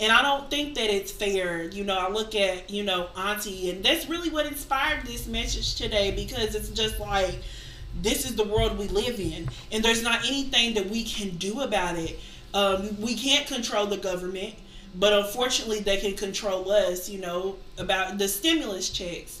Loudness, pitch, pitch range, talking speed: -26 LUFS, 205 Hz, 185-230 Hz, 190 wpm